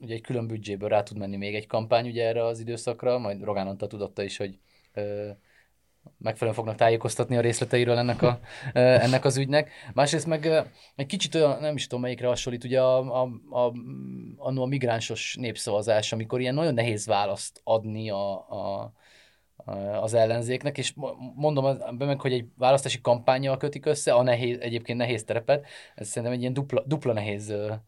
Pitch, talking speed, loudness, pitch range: 120 Hz, 180 wpm, -27 LUFS, 110-130 Hz